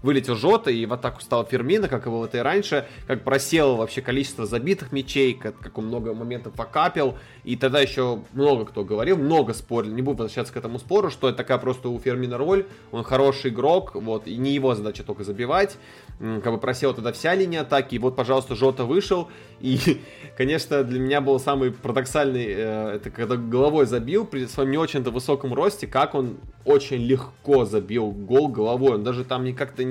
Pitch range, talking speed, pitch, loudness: 120-140 Hz, 190 wpm, 130 Hz, -23 LUFS